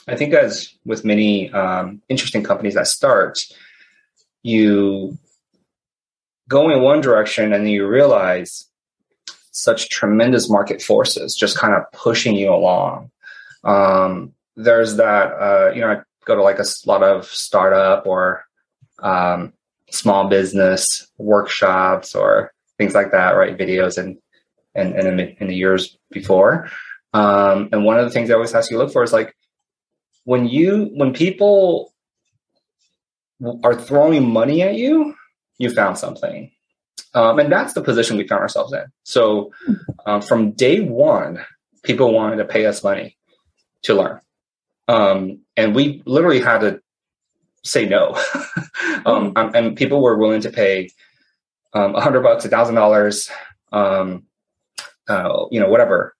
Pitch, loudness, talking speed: 115 Hz, -16 LUFS, 145 wpm